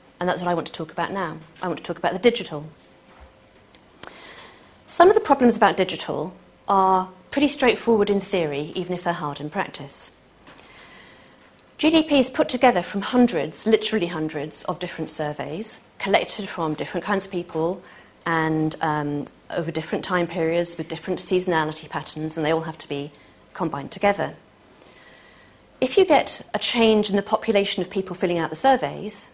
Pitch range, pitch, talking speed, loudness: 160-210 Hz, 180 Hz, 170 wpm, -23 LUFS